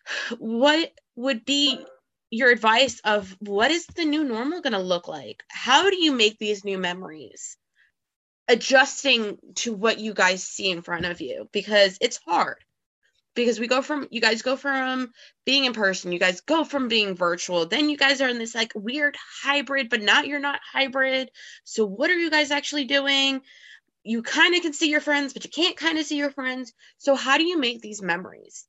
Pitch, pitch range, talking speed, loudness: 260 Hz, 215-285 Hz, 200 wpm, -22 LUFS